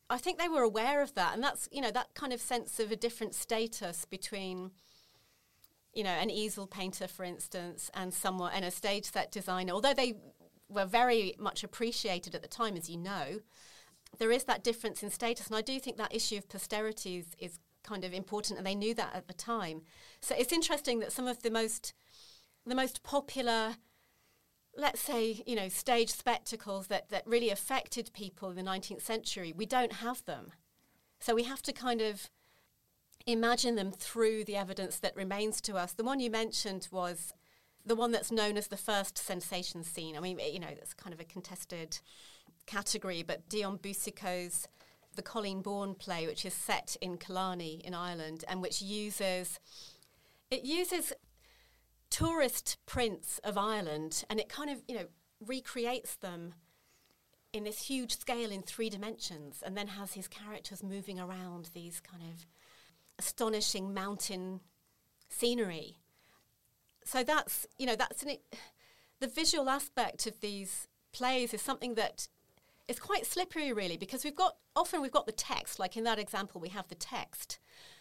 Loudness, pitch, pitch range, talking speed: -36 LUFS, 210 Hz, 185-235 Hz, 175 wpm